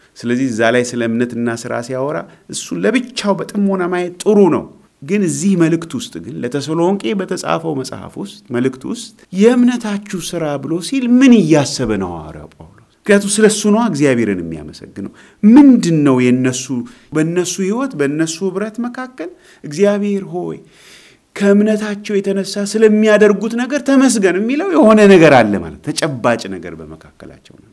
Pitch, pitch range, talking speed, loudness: 180 Hz, 130-215 Hz, 130 wpm, -14 LUFS